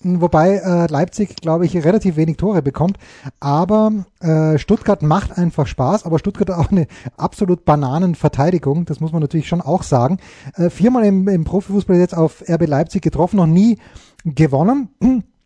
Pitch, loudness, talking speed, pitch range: 175 Hz, -16 LUFS, 150 wpm, 155-195 Hz